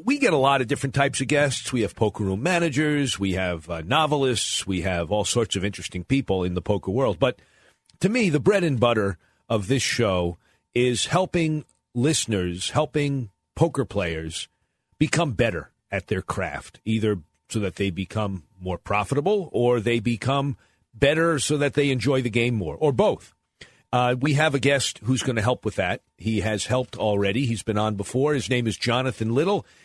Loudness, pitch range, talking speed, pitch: -24 LUFS, 100-140 Hz, 190 wpm, 120 Hz